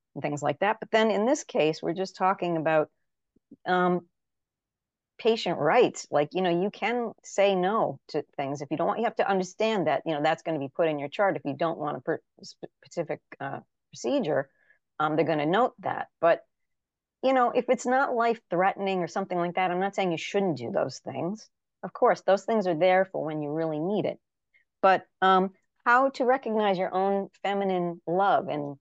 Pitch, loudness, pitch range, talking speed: 185 Hz, -27 LUFS, 160-205 Hz, 210 wpm